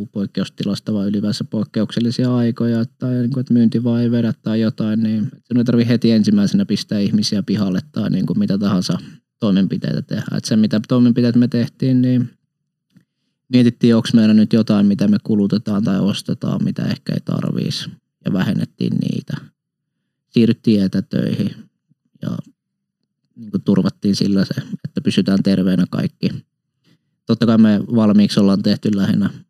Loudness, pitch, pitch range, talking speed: -17 LUFS, 115 Hz, 105-130 Hz, 145 wpm